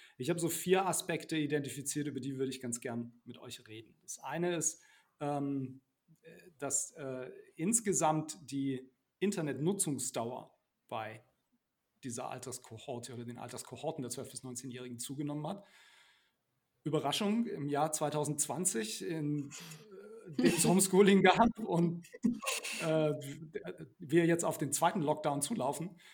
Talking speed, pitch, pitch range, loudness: 125 wpm, 150 Hz, 135-170 Hz, -34 LUFS